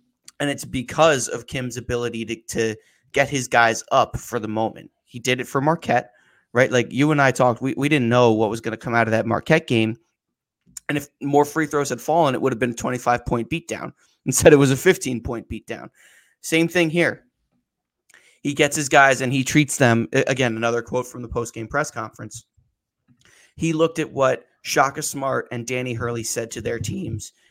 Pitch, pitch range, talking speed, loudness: 125 Hz, 115-145 Hz, 205 wpm, -21 LUFS